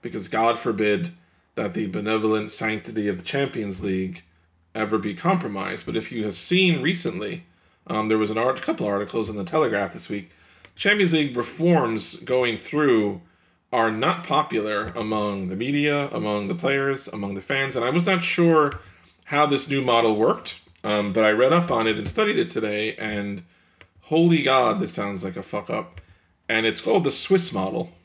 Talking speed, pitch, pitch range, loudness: 185 wpm, 110 Hz, 100-140 Hz, -23 LUFS